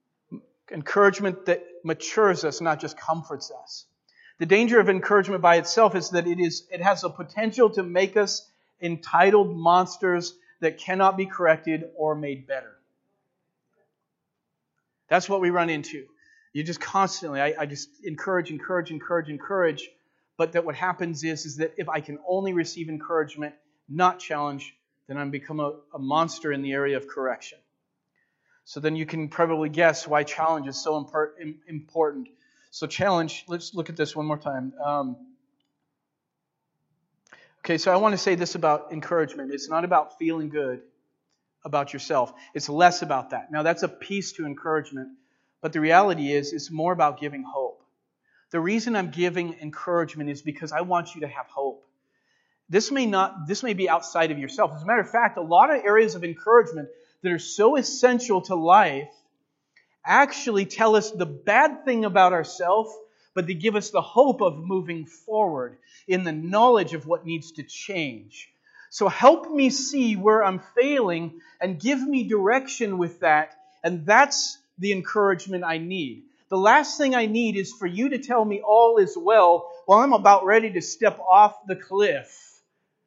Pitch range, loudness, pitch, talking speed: 155-205 Hz, -23 LUFS, 175 Hz, 170 wpm